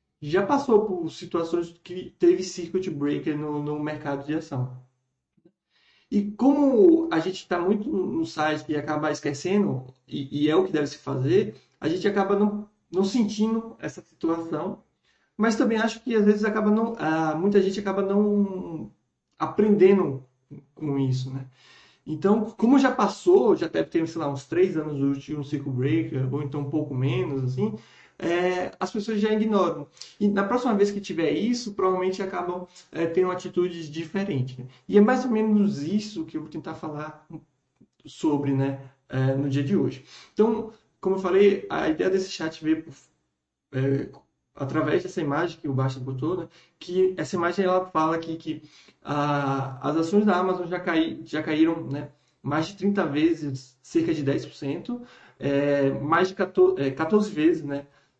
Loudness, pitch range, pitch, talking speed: -25 LUFS, 145-200 Hz, 165 Hz, 170 wpm